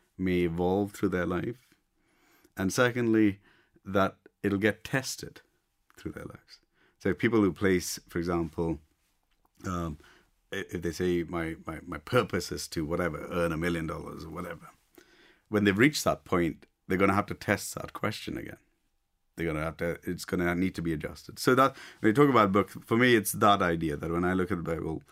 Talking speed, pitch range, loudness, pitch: 200 wpm, 85-100 Hz, -29 LUFS, 90 Hz